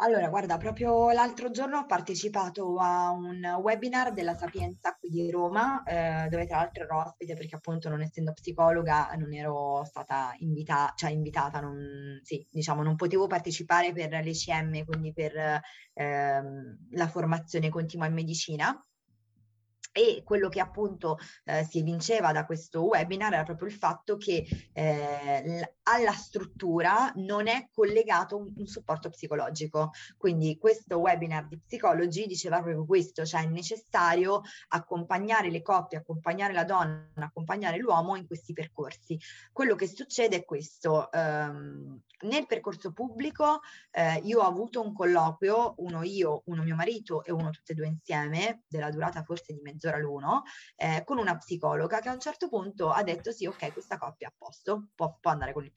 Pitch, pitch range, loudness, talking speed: 170 Hz, 155-200 Hz, -30 LUFS, 160 wpm